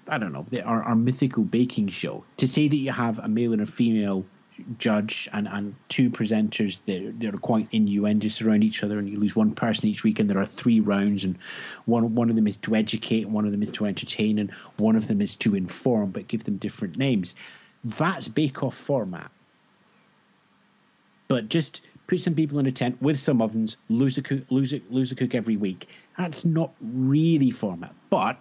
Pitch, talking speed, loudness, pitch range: 115 Hz, 210 wpm, -25 LUFS, 105-140 Hz